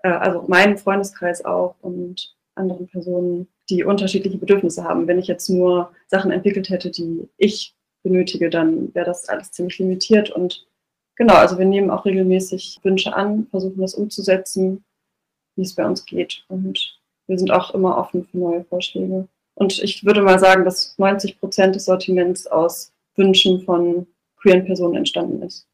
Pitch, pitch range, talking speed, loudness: 185 Hz, 180-195 Hz, 165 wpm, -18 LUFS